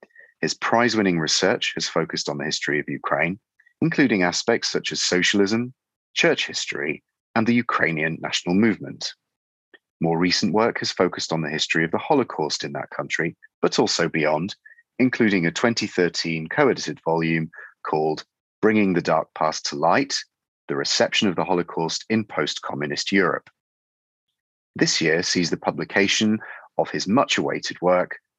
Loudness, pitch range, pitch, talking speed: -22 LUFS, 80-115 Hz, 90 Hz, 150 wpm